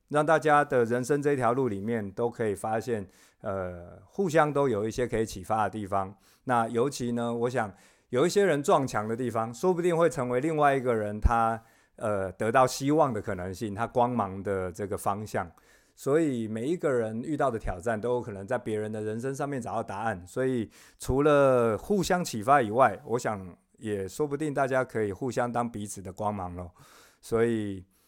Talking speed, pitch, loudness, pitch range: 280 characters per minute, 115 Hz, -28 LUFS, 105-130 Hz